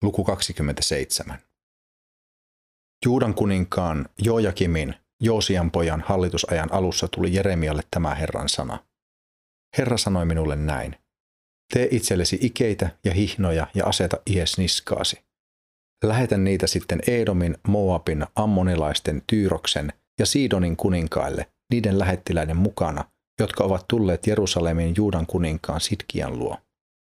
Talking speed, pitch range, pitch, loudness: 105 wpm, 80-105 Hz, 90 Hz, -23 LUFS